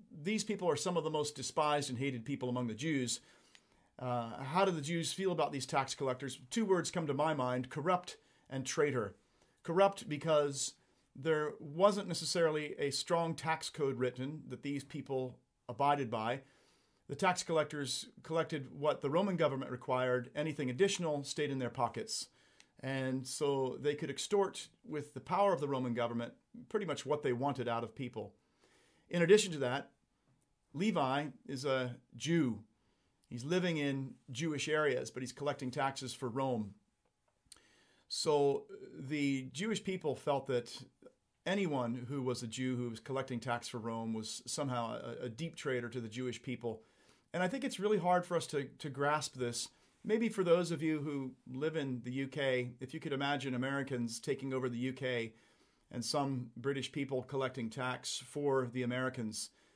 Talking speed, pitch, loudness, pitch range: 170 wpm, 140 Hz, -37 LUFS, 125-160 Hz